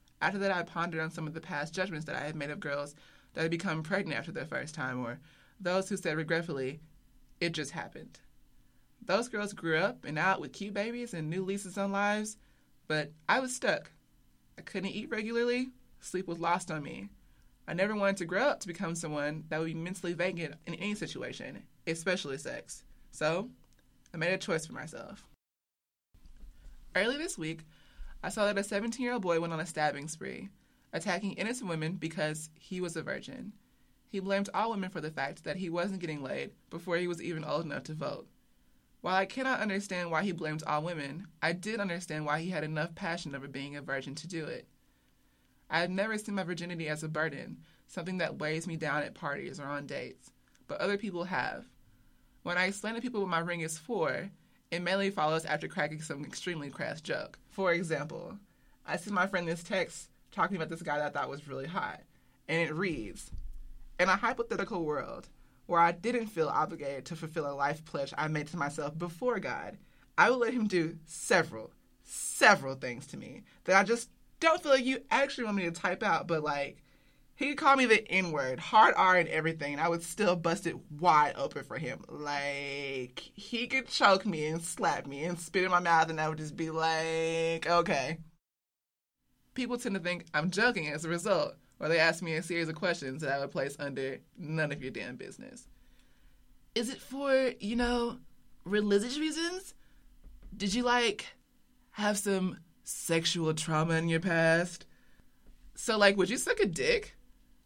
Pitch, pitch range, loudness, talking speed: 170 Hz, 155-195 Hz, -32 LUFS, 195 wpm